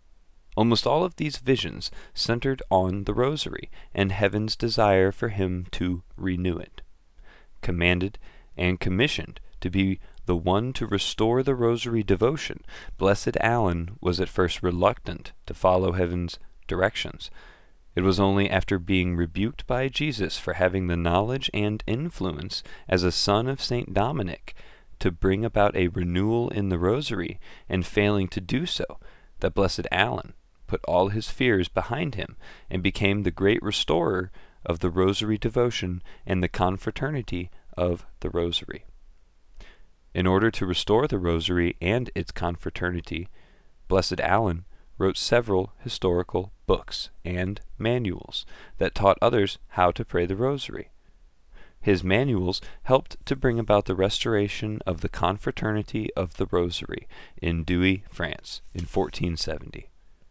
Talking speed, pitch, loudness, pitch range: 140 wpm, 95 Hz, -26 LUFS, 90-110 Hz